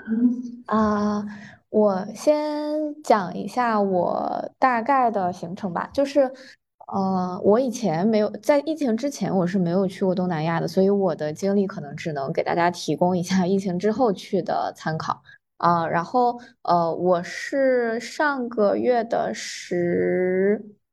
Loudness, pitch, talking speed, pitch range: -23 LUFS, 205 Hz, 230 characters per minute, 180-245 Hz